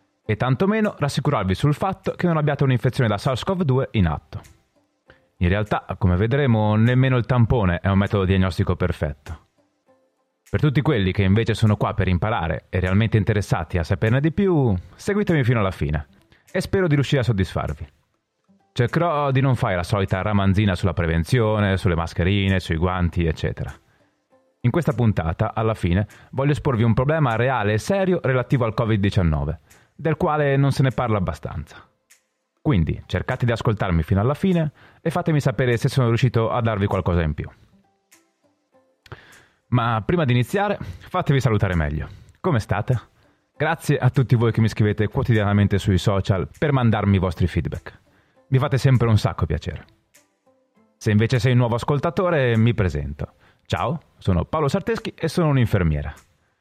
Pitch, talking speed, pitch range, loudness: 115 Hz, 160 wpm, 95-140 Hz, -21 LUFS